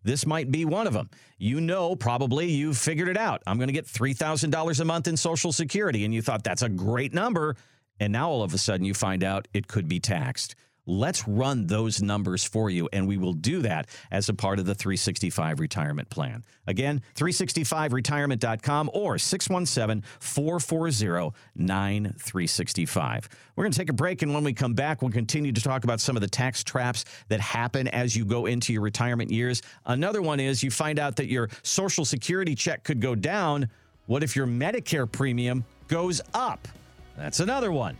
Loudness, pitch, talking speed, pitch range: -27 LUFS, 130 Hz, 195 wpm, 110-155 Hz